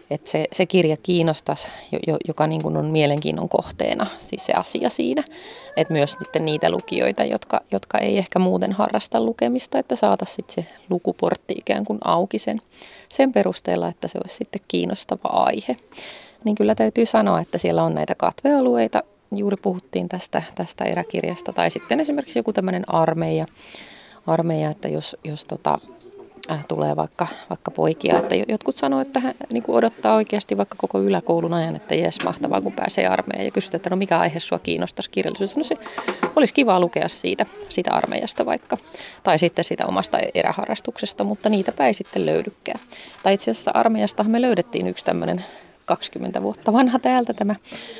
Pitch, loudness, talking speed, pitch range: 180 Hz, -22 LUFS, 160 wpm, 155-220 Hz